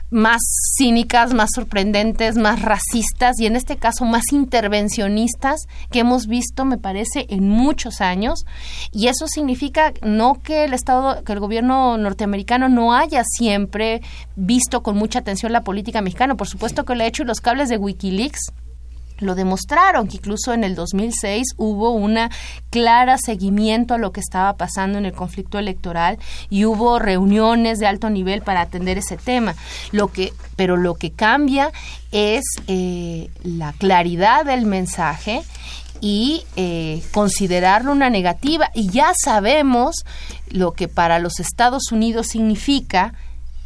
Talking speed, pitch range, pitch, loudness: 150 wpm, 195-245 Hz, 220 Hz, -18 LUFS